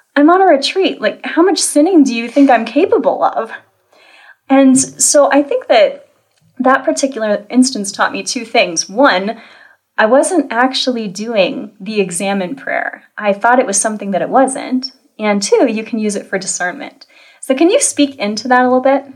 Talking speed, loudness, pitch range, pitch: 185 wpm, -13 LUFS, 215-285 Hz, 255 Hz